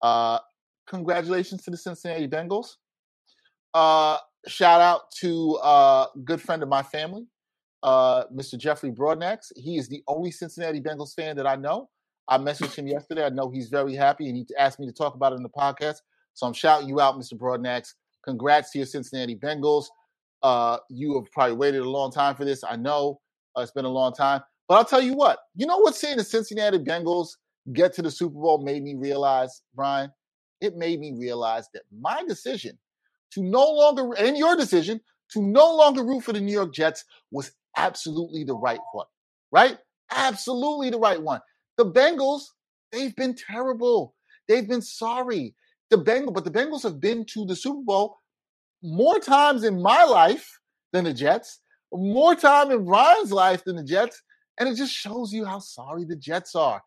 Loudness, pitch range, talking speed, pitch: -23 LUFS, 140-225 Hz, 190 wpm, 170 Hz